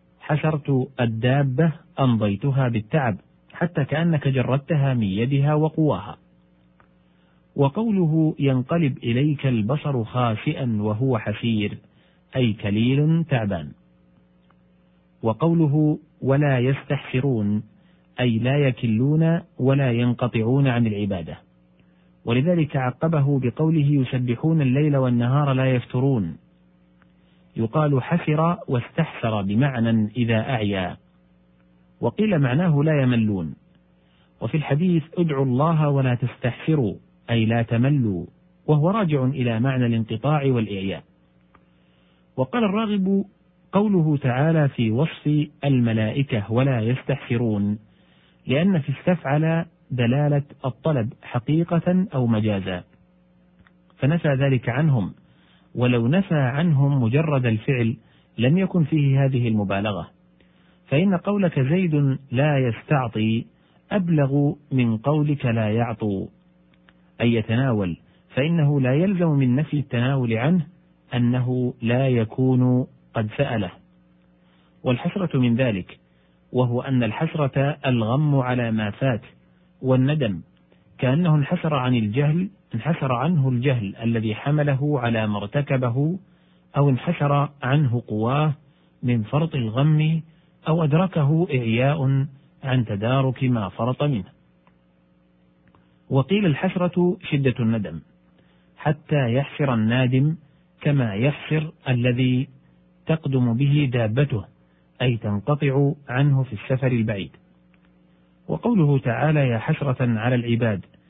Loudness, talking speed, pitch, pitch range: -22 LUFS, 95 wpm, 130 Hz, 110-150 Hz